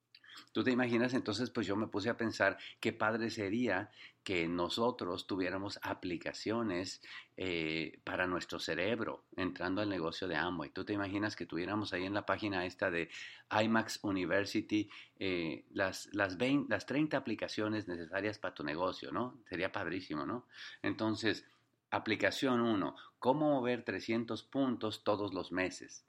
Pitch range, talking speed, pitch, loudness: 100-120 Hz, 145 wpm, 110 Hz, -36 LUFS